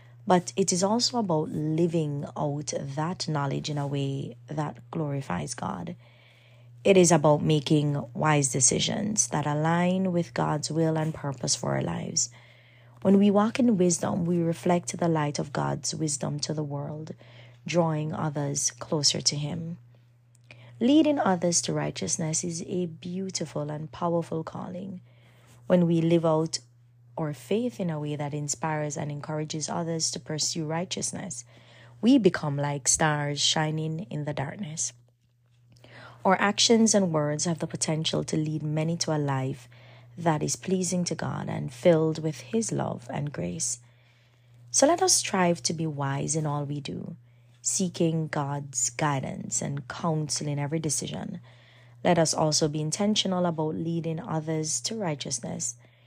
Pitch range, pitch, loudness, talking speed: 140-175 Hz, 155 Hz, -27 LUFS, 150 wpm